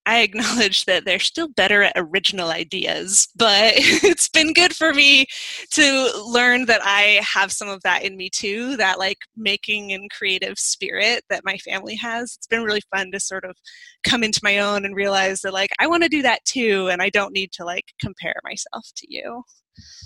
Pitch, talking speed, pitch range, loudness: 210 Hz, 200 wpm, 195-255 Hz, -18 LUFS